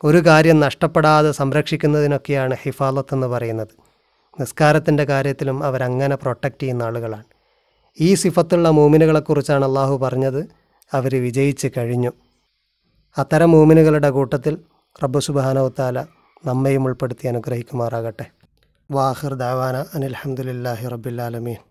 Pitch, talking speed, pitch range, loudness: 135 Hz, 90 wpm, 125-150 Hz, -18 LUFS